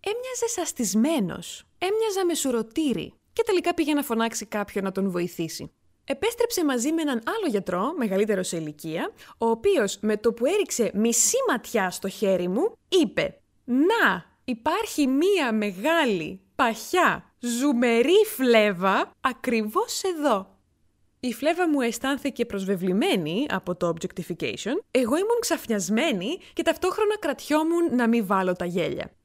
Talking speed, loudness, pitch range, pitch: 130 wpm, -25 LUFS, 200-330 Hz, 245 Hz